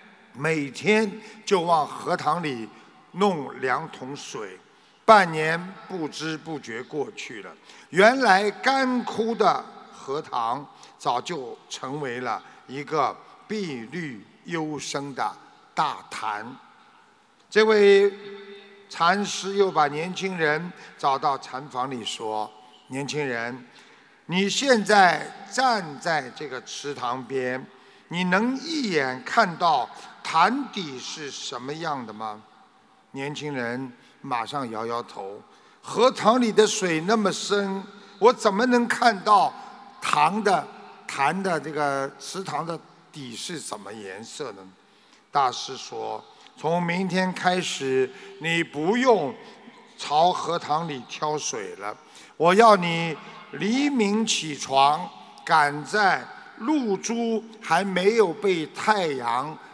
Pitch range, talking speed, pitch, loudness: 150-215 Hz, 155 characters per minute, 185 Hz, -24 LUFS